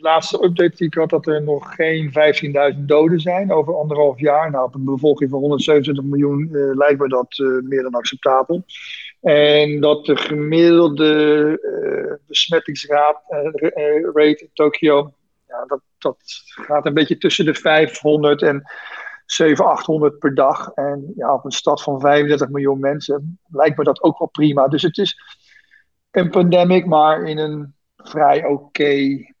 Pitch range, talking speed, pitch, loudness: 145-160 Hz, 160 wpm, 150 Hz, -16 LUFS